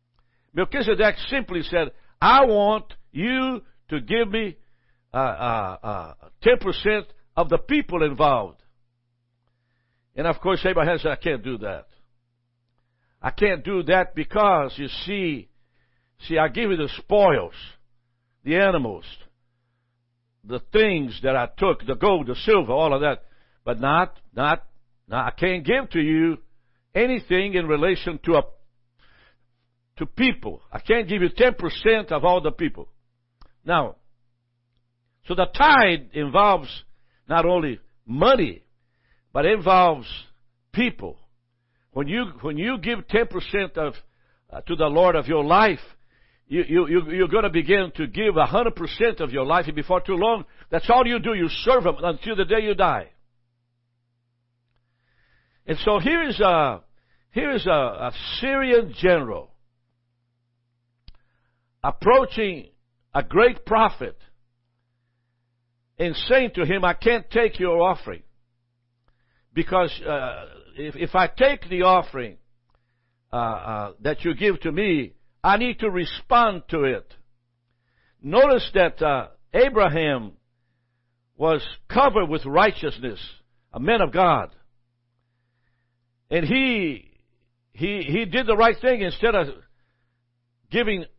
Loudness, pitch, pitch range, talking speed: -22 LUFS, 150 Hz, 120-195 Hz, 135 wpm